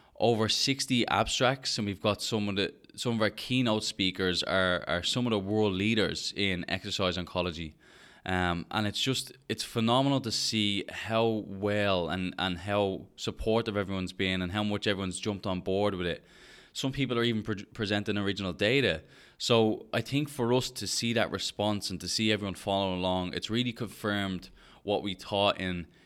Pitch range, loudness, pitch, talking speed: 95-115 Hz, -30 LUFS, 105 Hz, 180 wpm